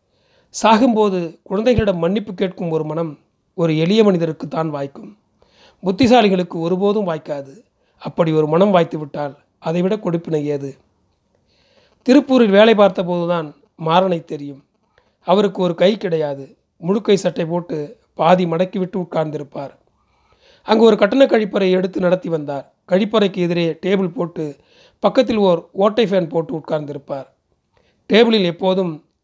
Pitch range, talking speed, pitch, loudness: 160-205 Hz, 115 wpm, 180 Hz, -17 LUFS